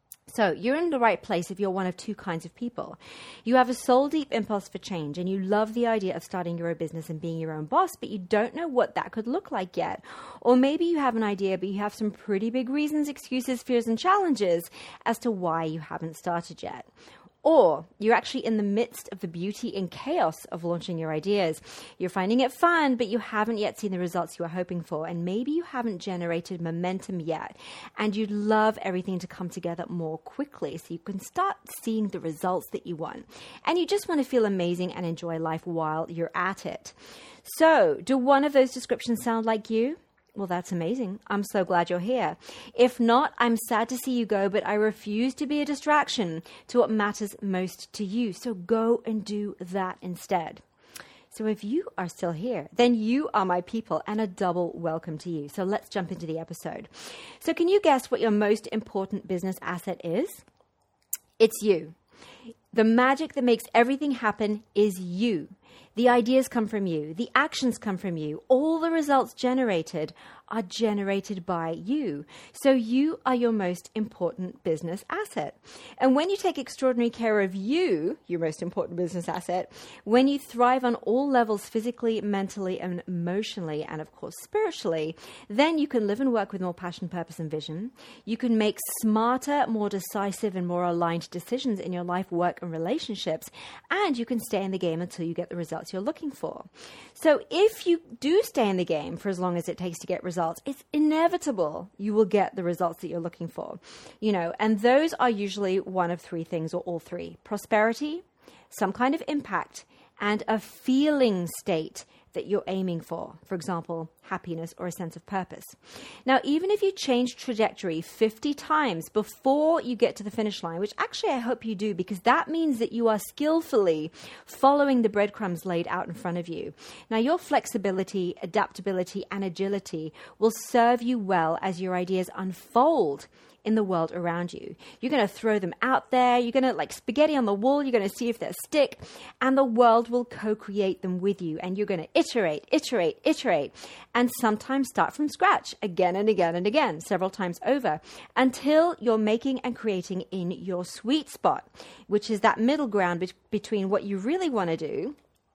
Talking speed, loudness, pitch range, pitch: 195 wpm, -27 LUFS, 180-250 Hz, 210 Hz